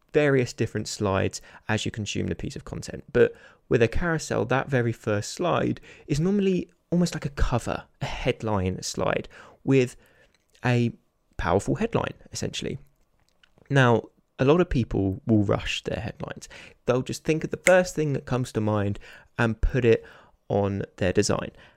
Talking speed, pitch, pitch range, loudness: 160 wpm, 120 Hz, 105-150 Hz, -26 LUFS